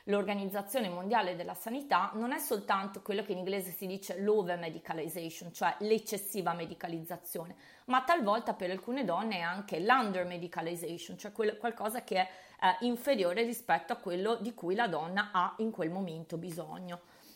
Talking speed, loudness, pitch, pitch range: 155 wpm, -34 LUFS, 195 Hz, 175-220 Hz